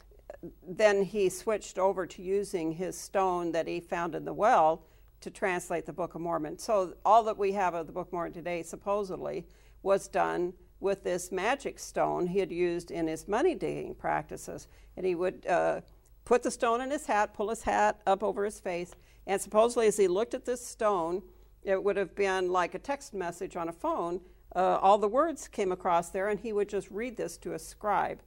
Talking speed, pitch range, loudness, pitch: 210 wpm, 180-210 Hz, -30 LUFS, 195 Hz